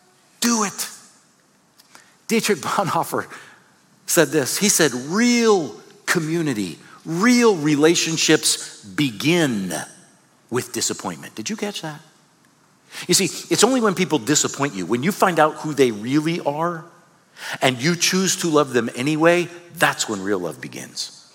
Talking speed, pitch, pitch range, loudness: 130 wpm, 170 Hz, 150-190 Hz, -20 LUFS